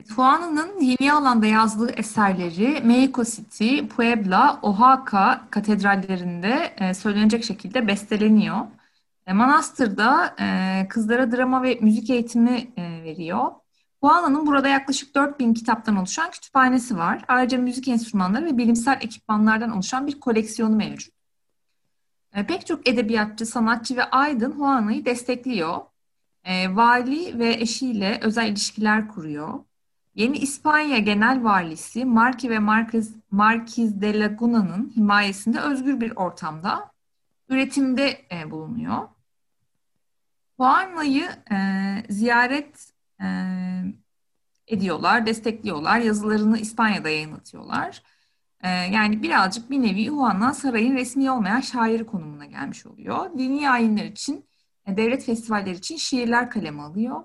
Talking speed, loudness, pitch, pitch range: 105 wpm, -21 LUFS, 230 Hz, 210-255 Hz